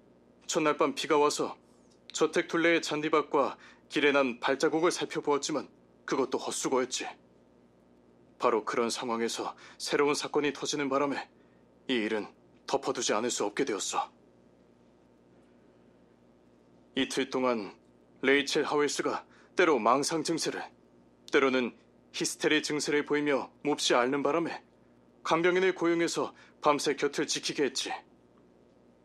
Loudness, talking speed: -29 LUFS, 260 characters per minute